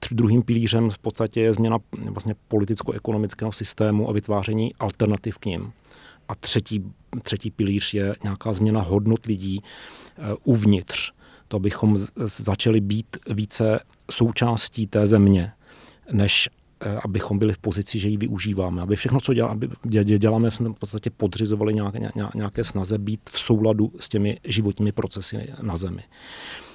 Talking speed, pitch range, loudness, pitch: 150 wpm, 105-115 Hz, -23 LUFS, 110 Hz